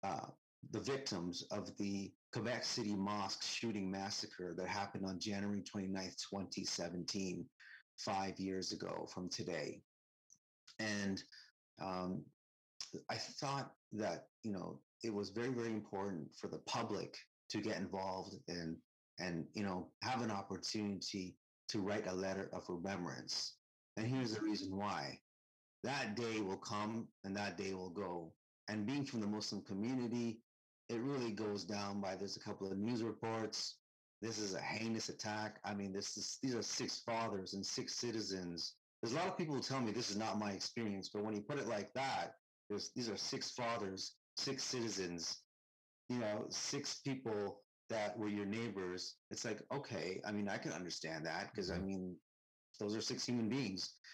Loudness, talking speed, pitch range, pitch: -43 LUFS, 165 wpm, 95-110 Hz, 100 Hz